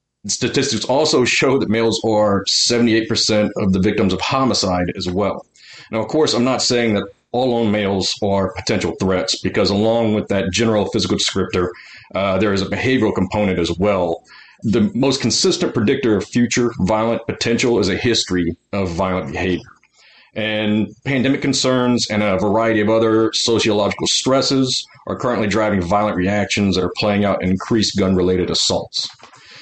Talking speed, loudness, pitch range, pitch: 160 wpm, -17 LUFS, 95-115 Hz, 105 Hz